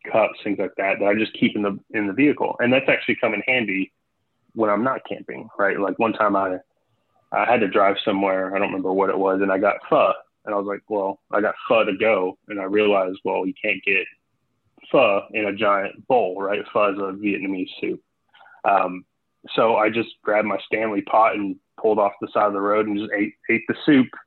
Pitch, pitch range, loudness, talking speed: 100 Hz, 95-105 Hz, -21 LUFS, 230 wpm